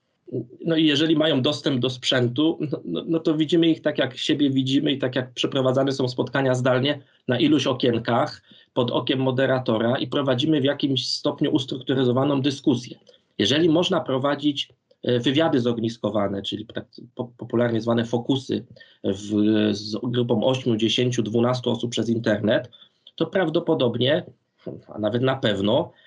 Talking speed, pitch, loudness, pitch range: 140 wpm, 130 Hz, -23 LUFS, 120-145 Hz